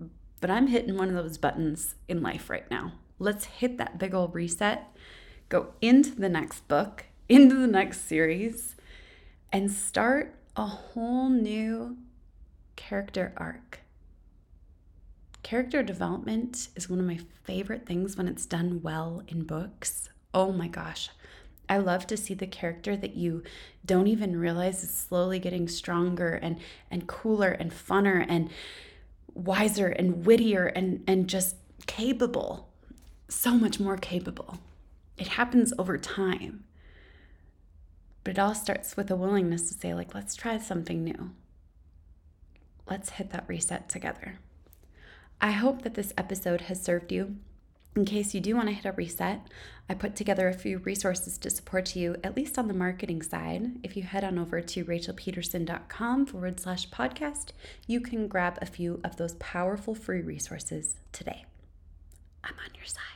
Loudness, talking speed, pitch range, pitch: -29 LUFS, 155 wpm, 160-205 Hz, 180 Hz